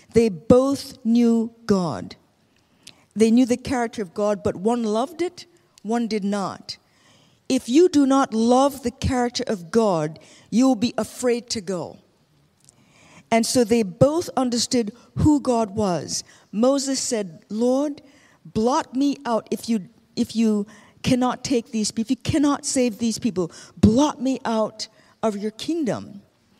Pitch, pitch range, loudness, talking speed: 230 Hz, 215-255 Hz, -22 LUFS, 150 wpm